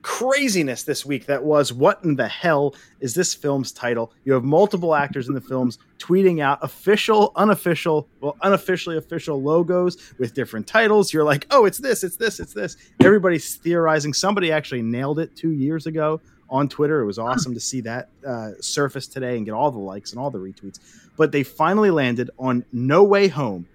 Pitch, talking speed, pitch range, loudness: 145 Hz, 195 wpm, 130-170 Hz, -20 LUFS